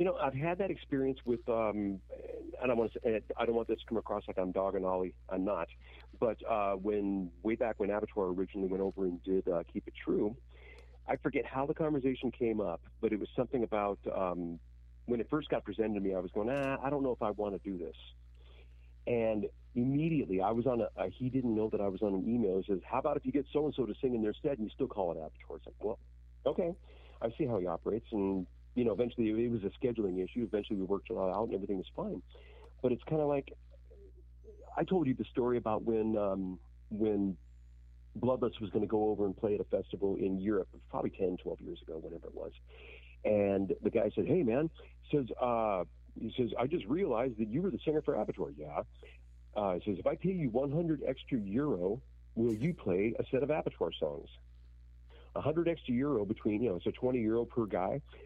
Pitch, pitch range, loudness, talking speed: 105 Hz, 75-120 Hz, -35 LUFS, 235 wpm